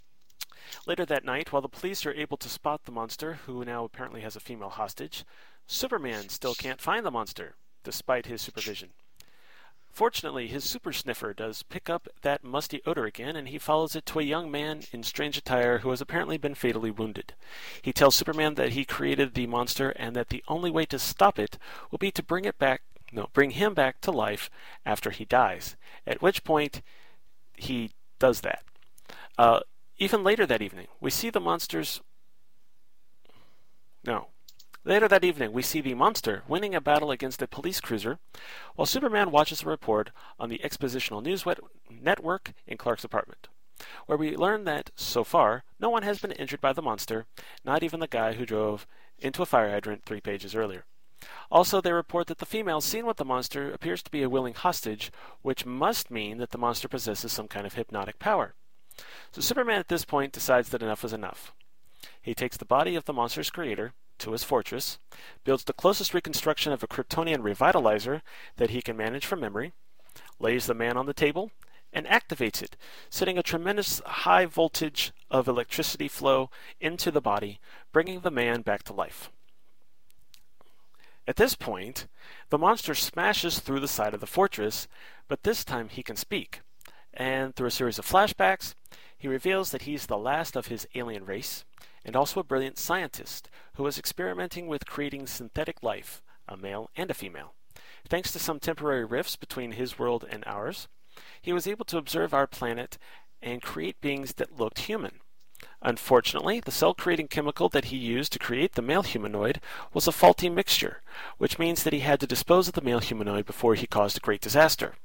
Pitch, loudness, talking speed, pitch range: 135 Hz, -28 LUFS, 185 wpm, 115-160 Hz